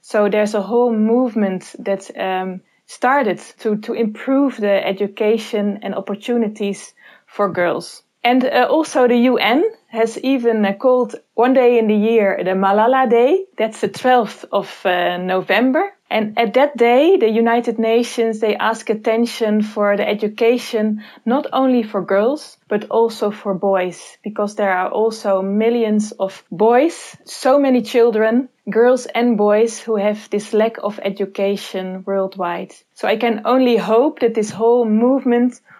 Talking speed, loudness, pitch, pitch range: 150 wpm, -17 LUFS, 225 Hz, 205-240 Hz